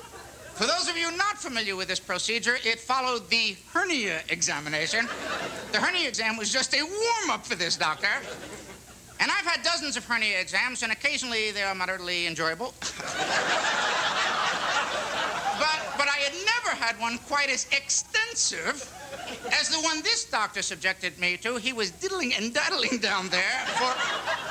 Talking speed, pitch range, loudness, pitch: 155 wpm, 195-315 Hz, -26 LUFS, 240 Hz